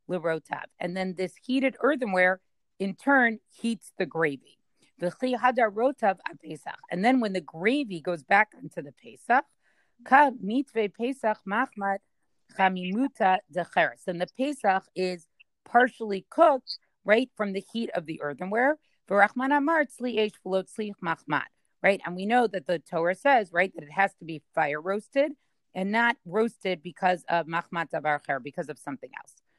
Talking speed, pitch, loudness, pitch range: 120 wpm, 195 Hz, -27 LUFS, 175-240 Hz